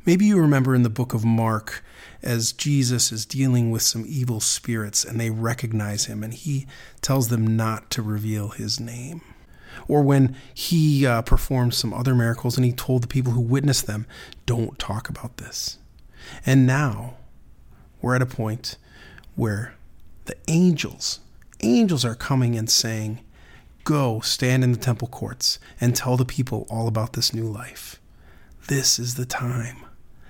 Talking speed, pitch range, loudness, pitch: 160 wpm, 110-130 Hz, -22 LUFS, 120 Hz